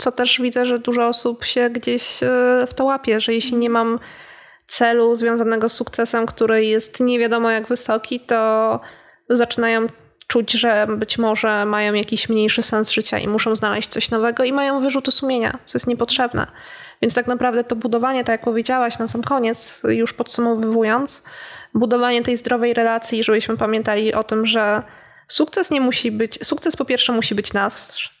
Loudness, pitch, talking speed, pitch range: -19 LUFS, 235 Hz, 170 wpm, 225-245 Hz